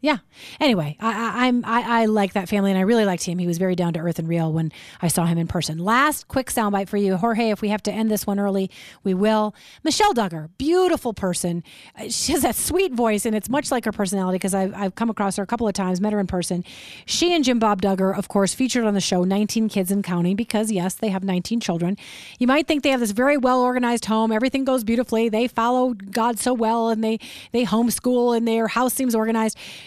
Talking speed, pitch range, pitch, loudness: 245 wpm, 195-240 Hz, 220 Hz, -21 LUFS